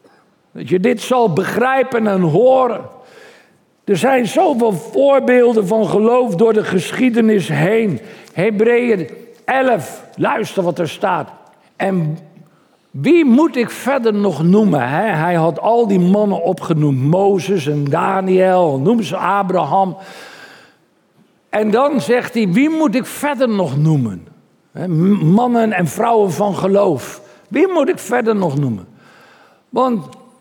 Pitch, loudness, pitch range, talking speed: 205 Hz, -15 LUFS, 180-240 Hz, 125 wpm